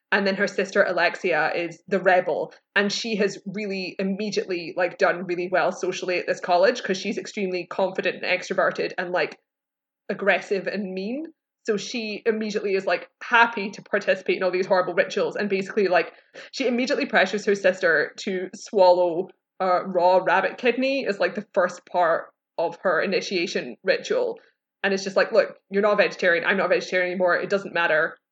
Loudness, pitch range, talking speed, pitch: -23 LUFS, 180-210 Hz, 180 wpm, 195 Hz